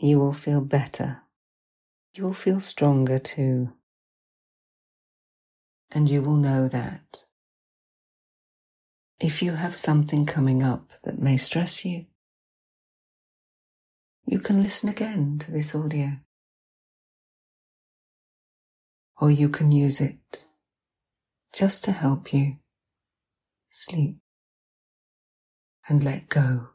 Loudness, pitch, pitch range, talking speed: -24 LUFS, 150 Hz, 140-170 Hz, 100 wpm